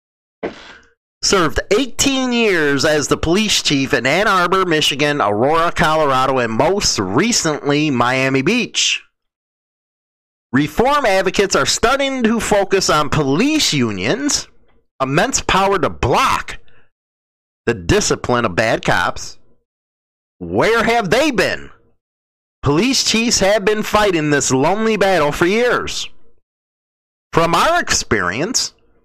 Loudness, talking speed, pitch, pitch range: -15 LUFS, 110 wpm, 180 Hz, 145-225 Hz